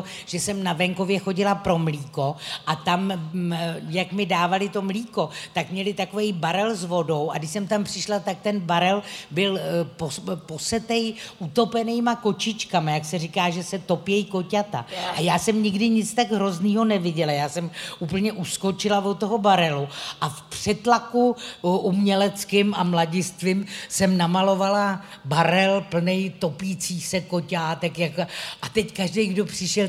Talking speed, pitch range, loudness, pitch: 145 wpm, 175-205 Hz, -24 LUFS, 190 Hz